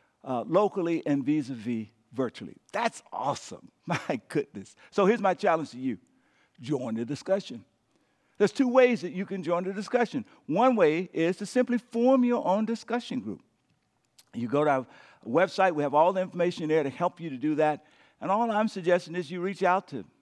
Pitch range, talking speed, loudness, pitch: 150-215 Hz, 195 wpm, -28 LUFS, 180 Hz